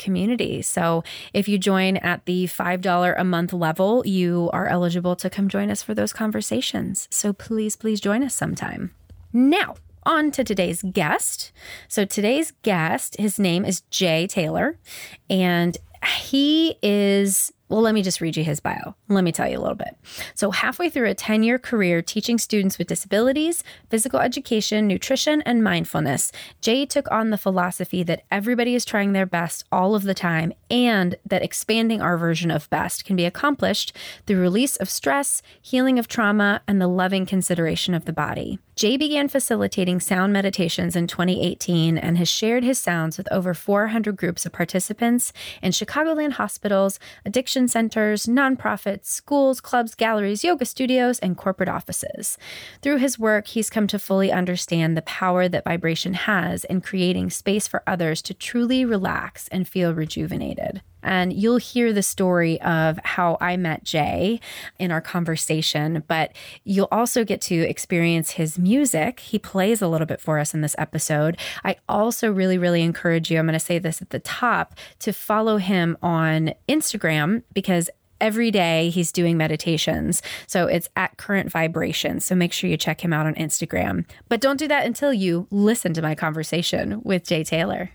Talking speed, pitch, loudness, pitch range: 170 wpm, 190 Hz, -22 LUFS, 170-220 Hz